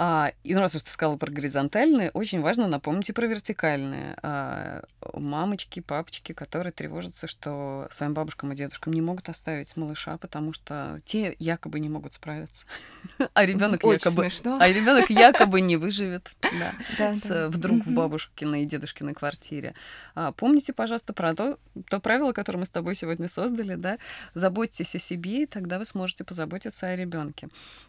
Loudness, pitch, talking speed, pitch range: -26 LUFS, 175 Hz, 145 wpm, 155-205 Hz